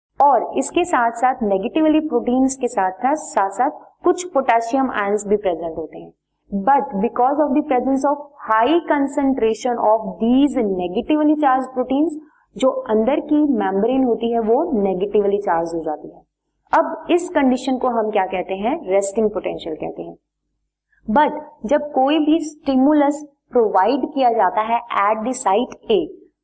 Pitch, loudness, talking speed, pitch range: 255 Hz, -18 LUFS, 145 wpm, 215-295 Hz